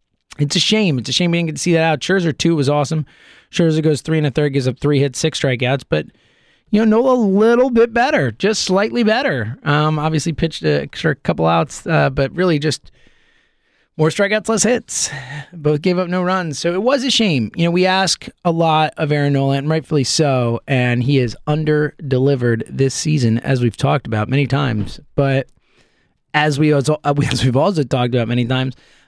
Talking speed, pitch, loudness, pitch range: 210 wpm, 150 Hz, -17 LUFS, 135-175 Hz